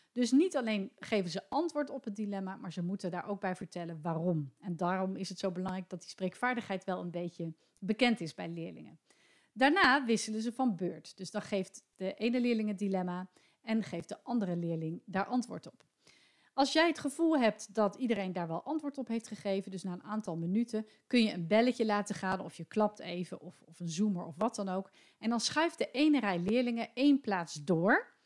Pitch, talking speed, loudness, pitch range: 205 Hz, 210 wpm, -34 LUFS, 185-240 Hz